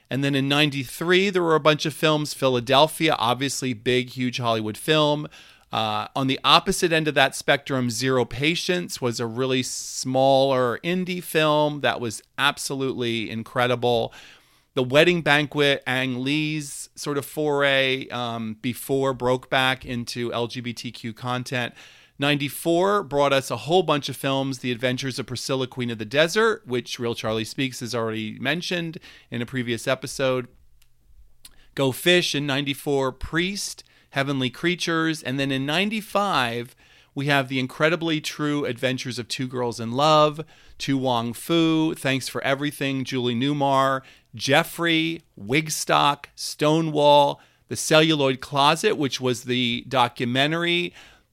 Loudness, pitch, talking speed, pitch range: -23 LUFS, 135 Hz, 140 wpm, 125-150 Hz